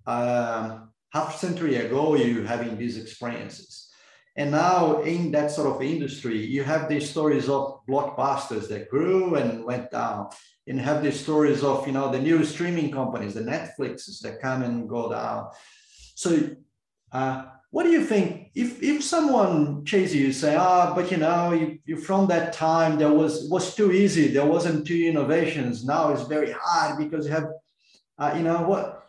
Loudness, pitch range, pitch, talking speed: -24 LUFS, 135-170 Hz, 150 Hz, 180 wpm